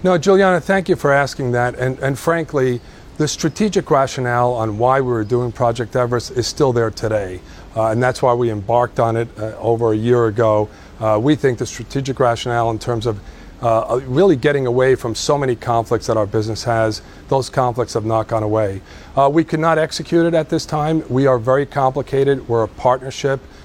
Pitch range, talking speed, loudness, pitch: 115-140 Hz, 205 wpm, -17 LUFS, 125 Hz